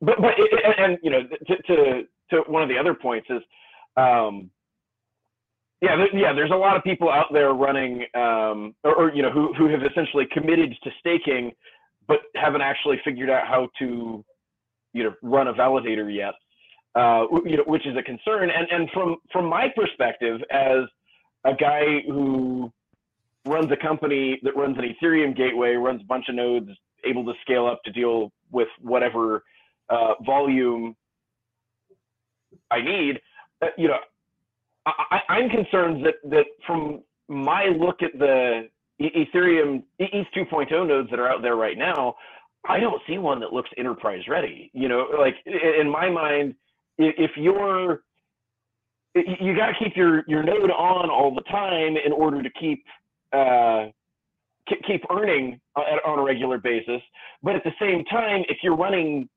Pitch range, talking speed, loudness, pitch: 125-170 Hz, 170 wpm, -22 LUFS, 145 Hz